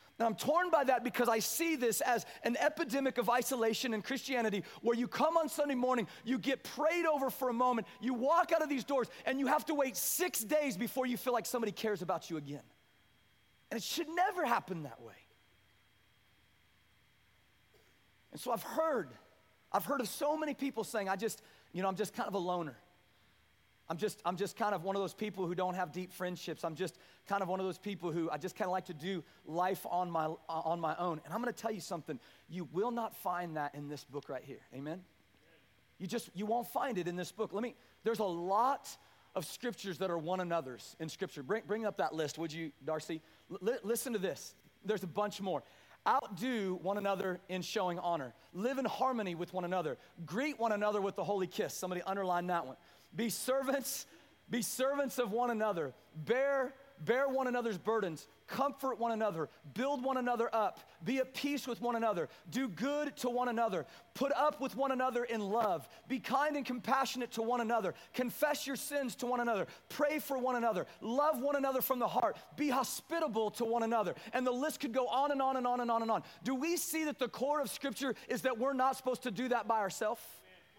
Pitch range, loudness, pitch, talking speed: 180-260 Hz, -36 LUFS, 225 Hz, 215 wpm